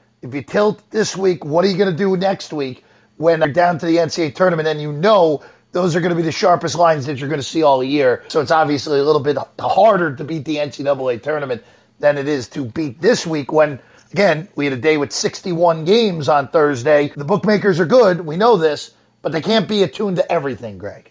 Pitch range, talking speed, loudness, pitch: 145-185 Hz, 235 wpm, -17 LUFS, 160 Hz